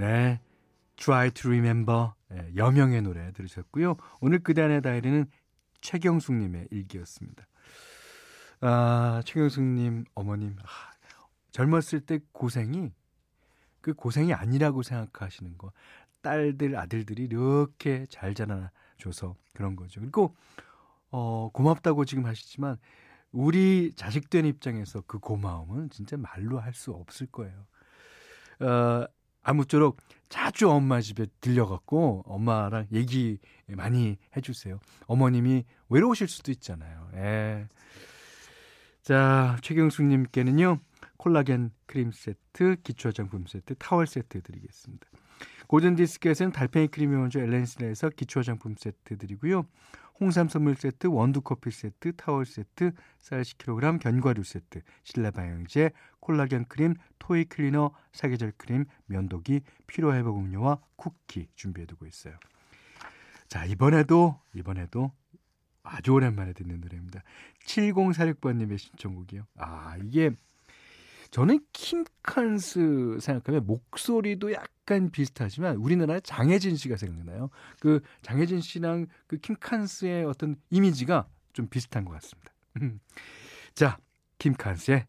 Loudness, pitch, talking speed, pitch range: -27 LUFS, 130 Hz, 280 characters per minute, 110-155 Hz